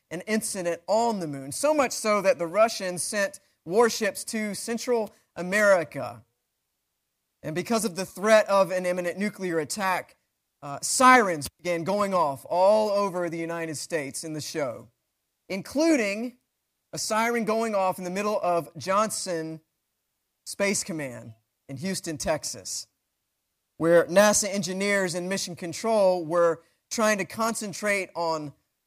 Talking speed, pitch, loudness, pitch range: 135 wpm, 190 Hz, -25 LUFS, 165-215 Hz